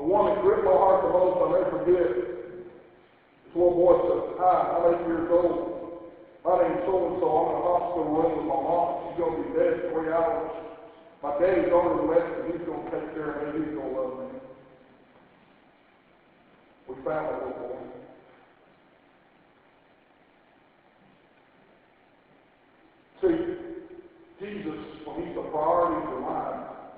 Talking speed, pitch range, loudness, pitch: 160 wpm, 160-180 Hz, -26 LUFS, 170 Hz